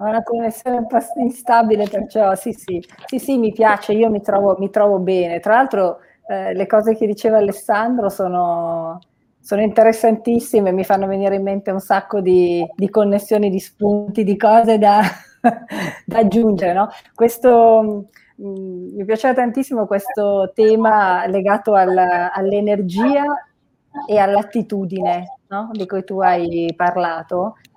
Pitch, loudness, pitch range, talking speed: 205 Hz, -16 LUFS, 195-225 Hz, 145 wpm